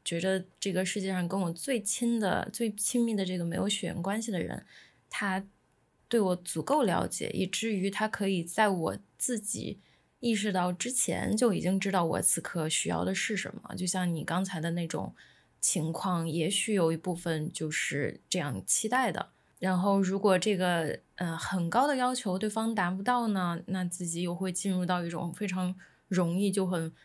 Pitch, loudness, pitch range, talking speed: 185 Hz, -30 LUFS, 175-210 Hz, 265 characters per minute